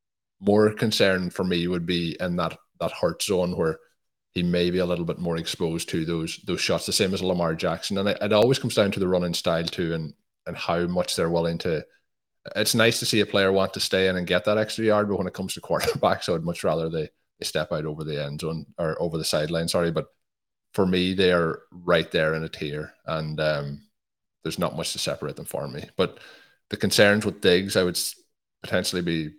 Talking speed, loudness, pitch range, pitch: 235 wpm, -25 LUFS, 80-95 Hz, 90 Hz